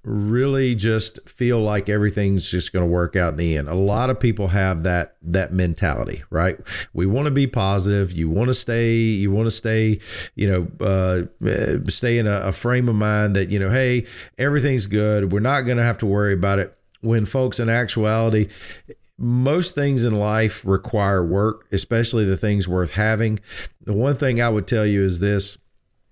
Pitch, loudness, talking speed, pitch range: 105 Hz, -20 LUFS, 195 wpm, 95-115 Hz